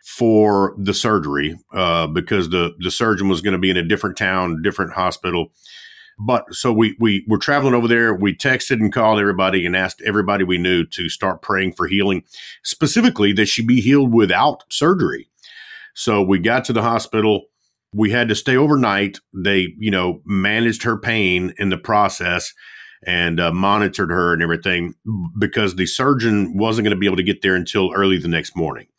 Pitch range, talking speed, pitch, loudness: 95-110 Hz, 185 wpm, 100 Hz, -18 LUFS